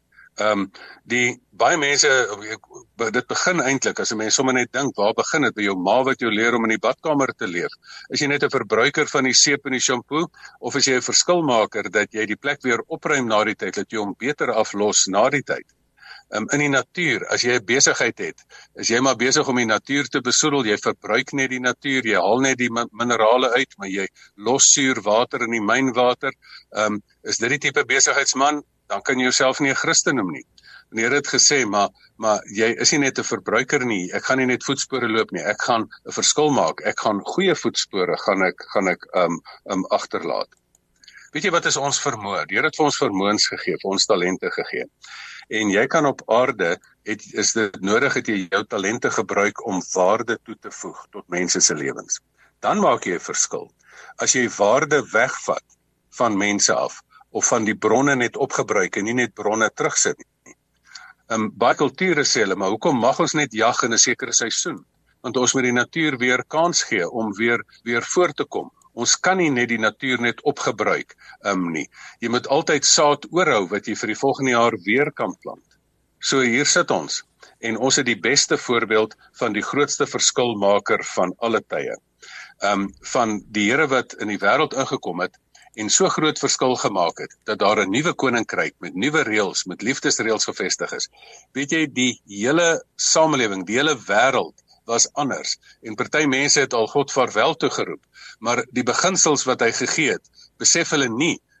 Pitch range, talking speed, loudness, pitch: 105-140 Hz, 200 wpm, -20 LUFS, 125 Hz